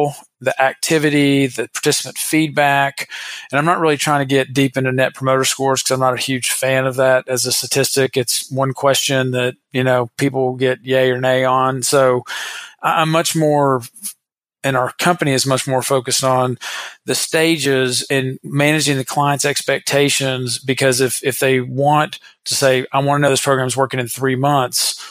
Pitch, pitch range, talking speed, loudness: 135 Hz, 130-145 Hz, 185 wpm, -16 LUFS